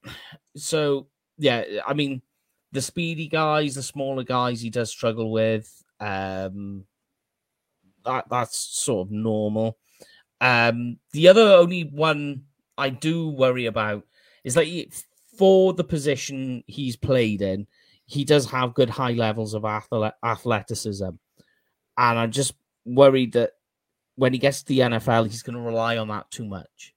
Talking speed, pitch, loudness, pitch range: 145 wpm, 125 Hz, -22 LUFS, 110-140 Hz